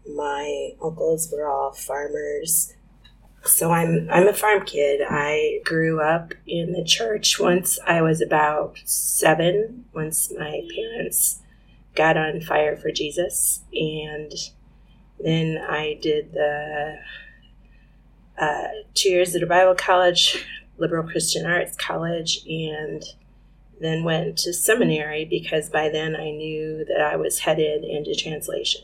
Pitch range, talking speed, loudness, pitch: 155-190 Hz, 130 wpm, -22 LUFS, 160 Hz